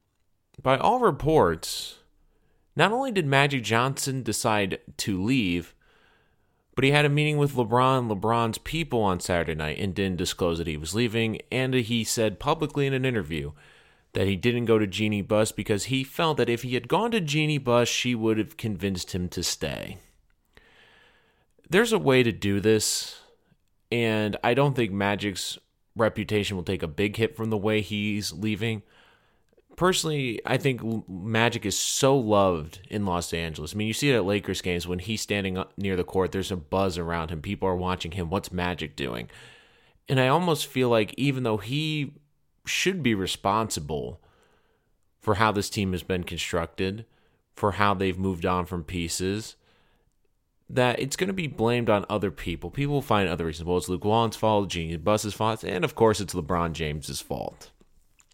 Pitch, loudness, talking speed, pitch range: 105 Hz, -26 LUFS, 180 wpm, 90-120 Hz